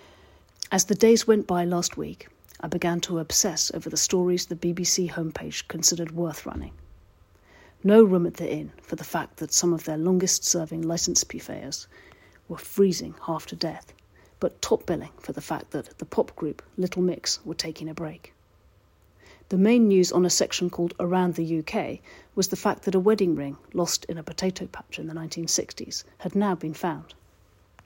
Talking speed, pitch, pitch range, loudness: 185 wpm, 170 Hz, 155-185 Hz, -25 LUFS